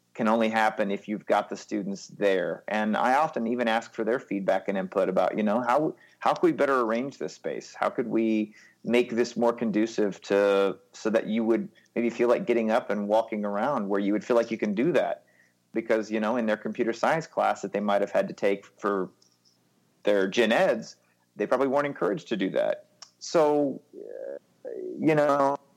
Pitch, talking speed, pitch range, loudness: 110 Hz, 205 wpm, 100-120 Hz, -26 LUFS